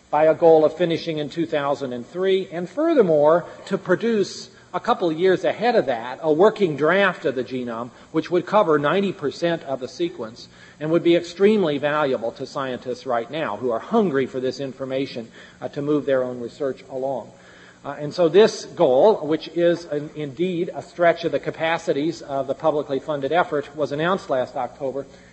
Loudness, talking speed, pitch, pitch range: -22 LUFS, 180 wpm, 155 Hz, 135-175 Hz